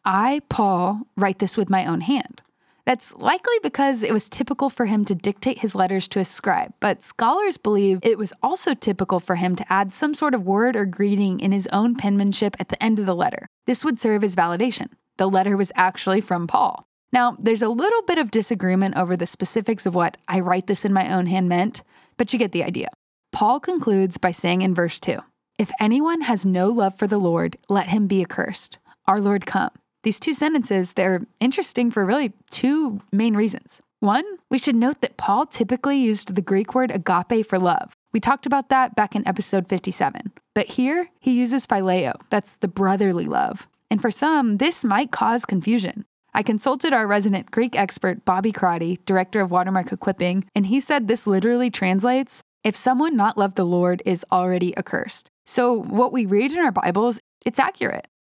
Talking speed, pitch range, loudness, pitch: 200 wpm, 190-250 Hz, -21 LUFS, 210 Hz